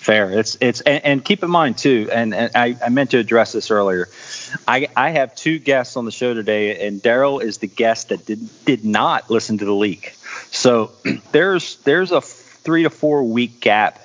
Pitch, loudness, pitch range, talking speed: 115 Hz, -17 LUFS, 110-135 Hz, 210 wpm